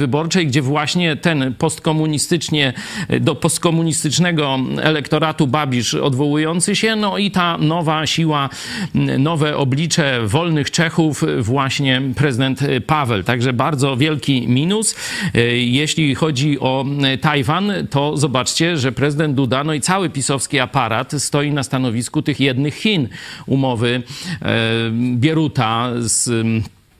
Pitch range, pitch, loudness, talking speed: 130-160 Hz, 145 Hz, -17 LUFS, 115 wpm